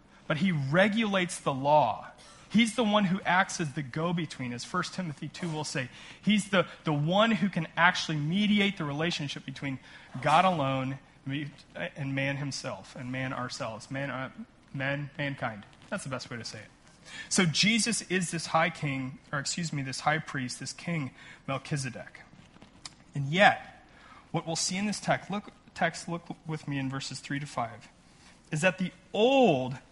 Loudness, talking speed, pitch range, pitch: -29 LUFS, 170 wpm, 135-185 Hz, 155 Hz